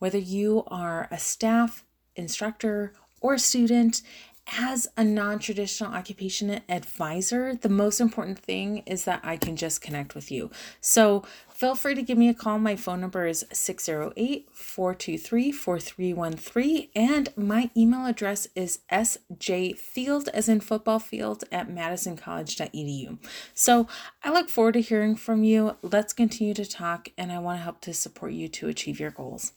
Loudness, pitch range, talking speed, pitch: -26 LUFS, 180-230 Hz, 150 wpm, 205 Hz